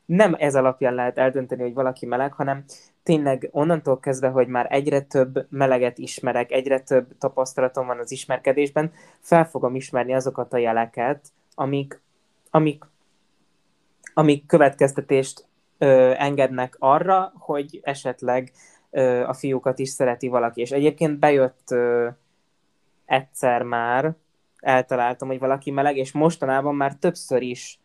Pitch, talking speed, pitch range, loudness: 135 Hz, 130 wpm, 130-145 Hz, -22 LUFS